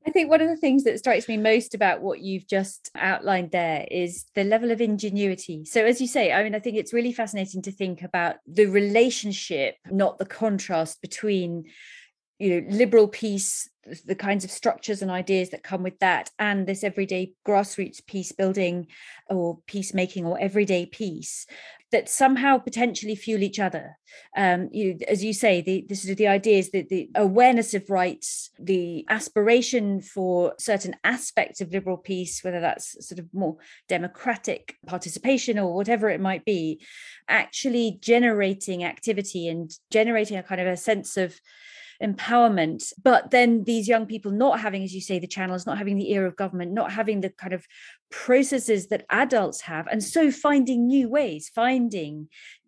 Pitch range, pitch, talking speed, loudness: 185-230 Hz, 200 Hz, 170 wpm, -24 LUFS